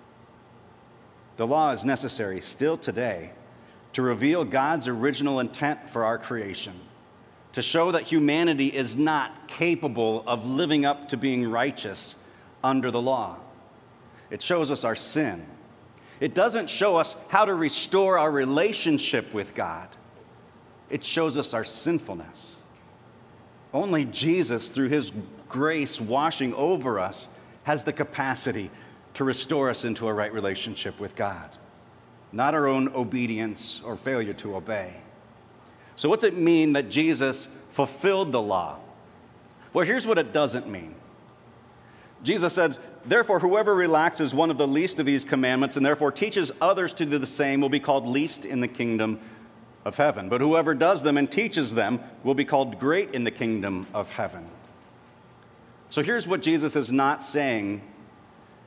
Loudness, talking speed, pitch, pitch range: -25 LUFS, 150 wpm, 135 Hz, 115-150 Hz